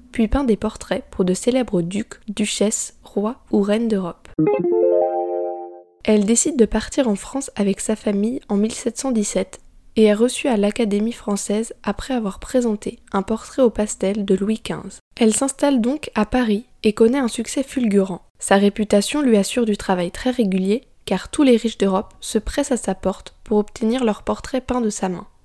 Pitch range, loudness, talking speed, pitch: 195-240 Hz, -20 LUFS, 180 wpm, 215 Hz